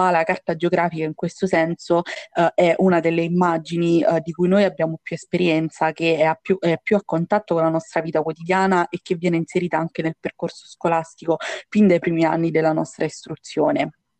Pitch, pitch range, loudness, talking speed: 170 Hz, 165-180 Hz, -21 LUFS, 190 wpm